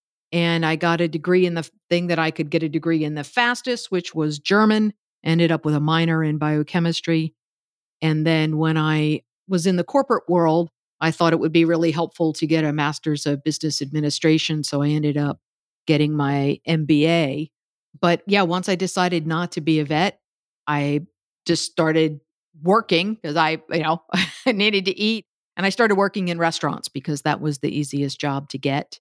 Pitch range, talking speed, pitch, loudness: 150-175 Hz, 190 wpm, 160 Hz, -21 LUFS